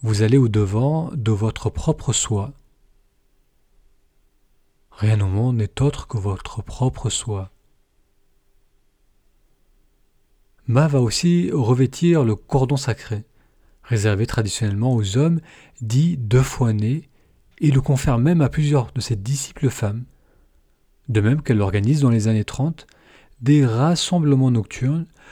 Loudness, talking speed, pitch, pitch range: -20 LUFS, 125 wpm, 115 Hz, 100-135 Hz